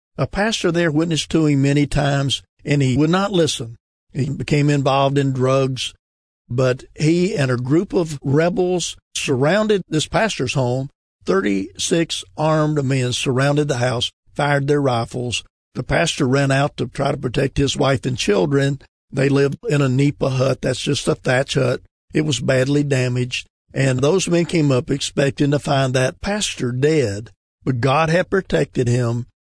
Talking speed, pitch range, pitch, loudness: 165 wpm, 125-155 Hz, 140 Hz, -19 LUFS